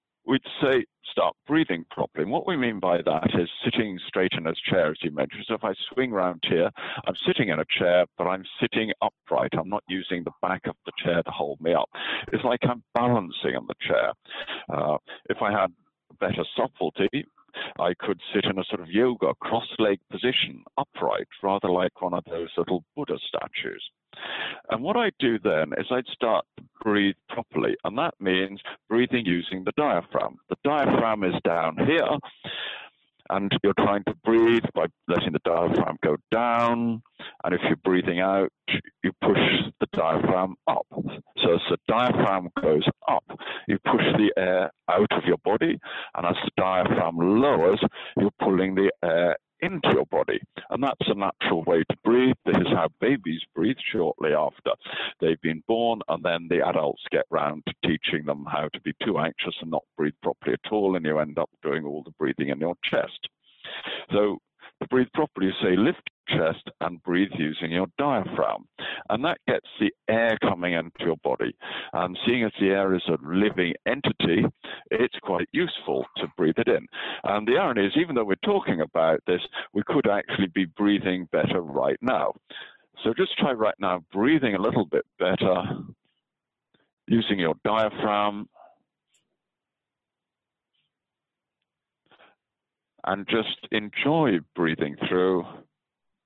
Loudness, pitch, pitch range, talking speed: -25 LUFS, 95 Hz, 90-115 Hz, 170 wpm